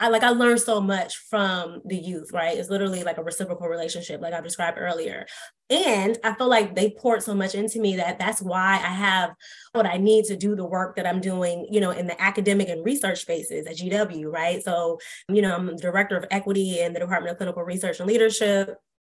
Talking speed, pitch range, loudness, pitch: 225 wpm, 175-210 Hz, -24 LUFS, 190 Hz